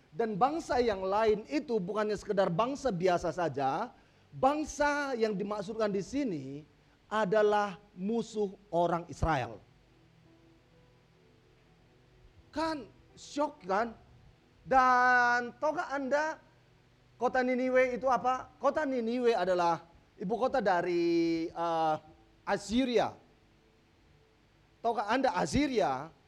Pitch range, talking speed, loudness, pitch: 170-255 Hz, 90 wpm, -31 LUFS, 215 Hz